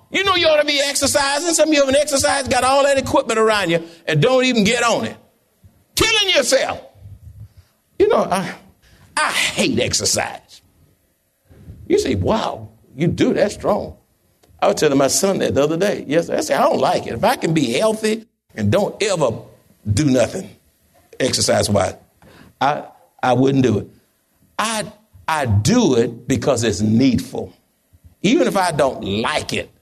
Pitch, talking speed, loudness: 215 Hz, 170 wpm, -17 LUFS